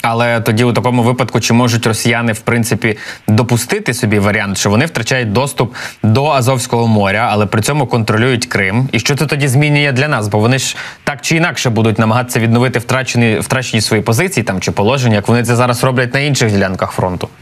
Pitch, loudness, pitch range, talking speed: 120 Hz, -13 LUFS, 110-130 Hz, 195 wpm